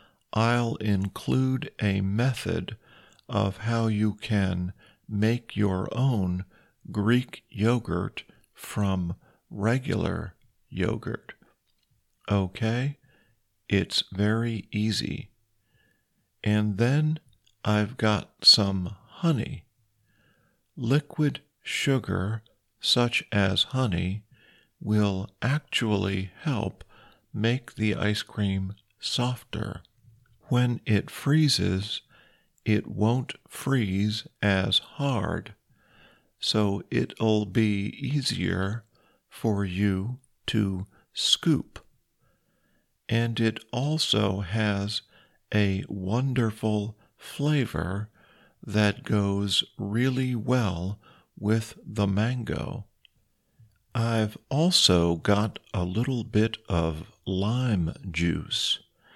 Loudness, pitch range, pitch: -27 LUFS, 100-120 Hz, 110 Hz